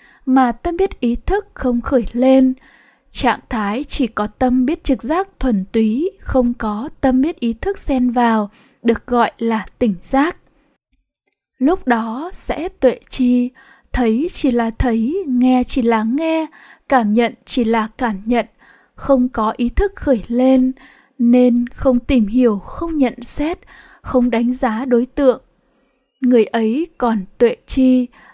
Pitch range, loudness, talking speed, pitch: 235-270 Hz, -17 LUFS, 155 wpm, 255 Hz